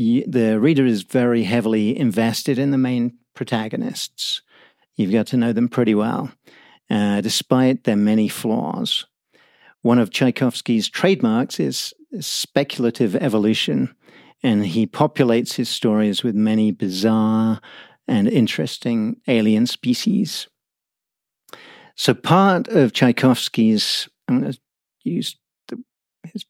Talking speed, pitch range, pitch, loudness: 115 wpm, 110-170 Hz, 120 Hz, -19 LUFS